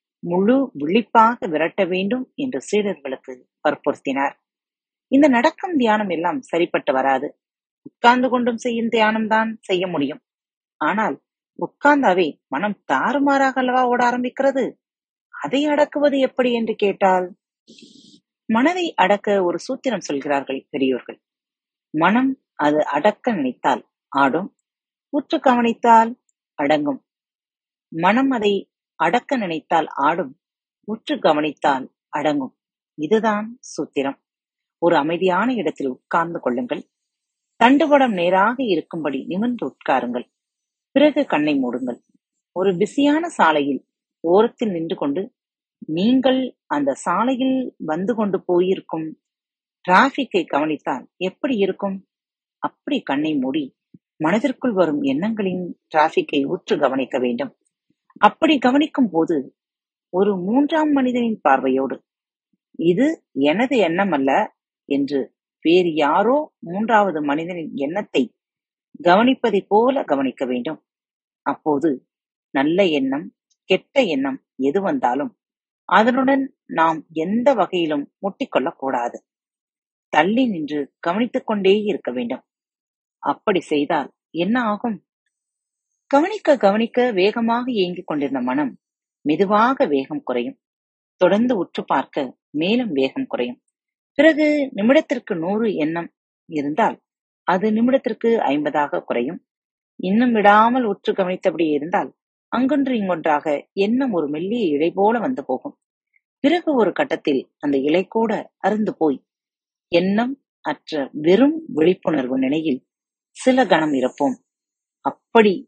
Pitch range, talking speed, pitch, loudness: 175-265 Hz, 100 wpm, 220 Hz, -20 LUFS